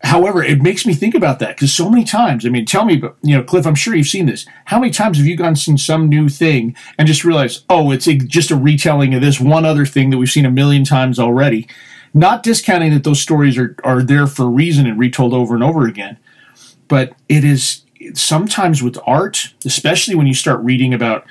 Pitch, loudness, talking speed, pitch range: 145 Hz, -13 LUFS, 235 wpm, 130-160 Hz